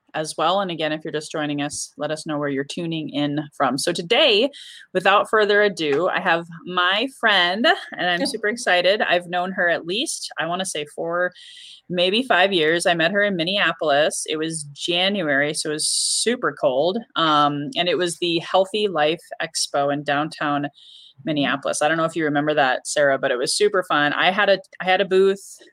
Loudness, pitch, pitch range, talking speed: -20 LUFS, 170 Hz, 150-195 Hz, 205 wpm